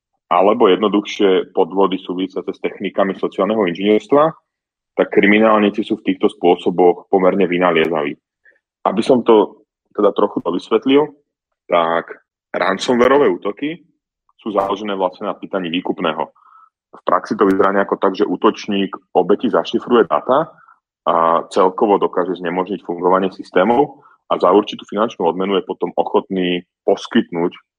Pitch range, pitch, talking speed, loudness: 90-110 Hz, 100 Hz, 125 wpm, -16 LUFS